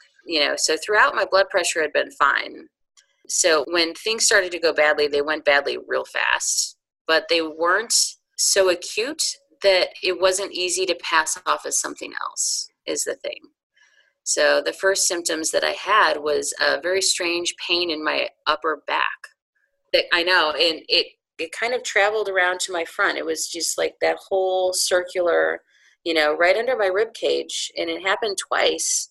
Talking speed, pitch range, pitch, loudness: 180 wpm, 165-250 Hz, 185 Hz, -20 LUFS